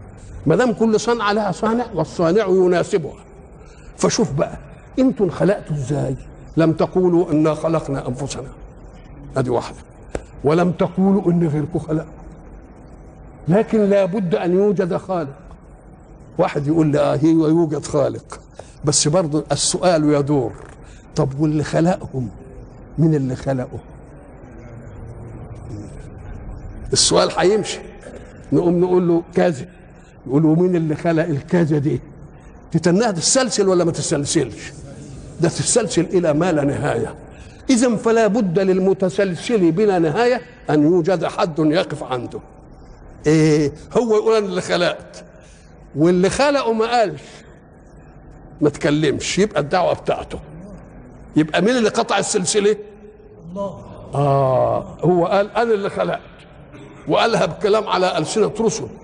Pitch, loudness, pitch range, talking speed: 165 Hz, -18 LUFS, 150-195 Hz, 110 wpm